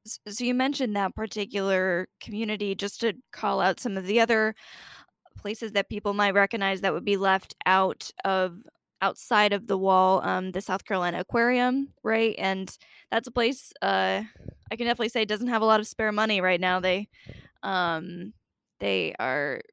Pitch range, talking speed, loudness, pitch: 190-225 Hz, 175 wpm, -26 LUFS, 205 Hz